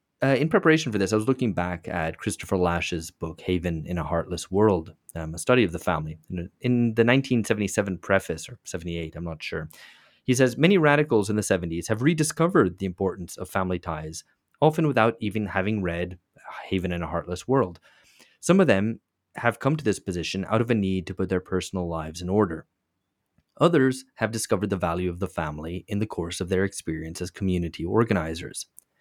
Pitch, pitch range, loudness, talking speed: 95 Hz, 85-115 Hz, -25 LUFS, 190 wpm